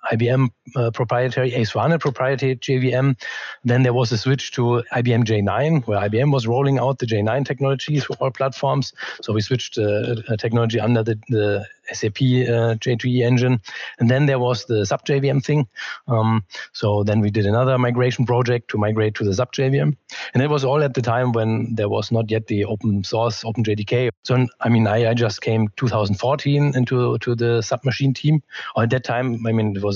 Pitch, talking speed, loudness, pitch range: 120 Hz, 200 wpm, -20 LUFS, 110-130 Hz